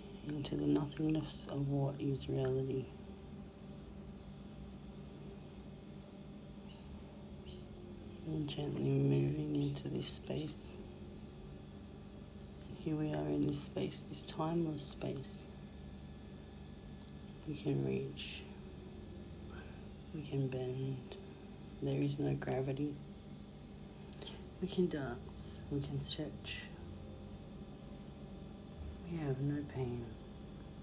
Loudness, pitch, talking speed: -41 LUFS, 130 Hz, 80 wpm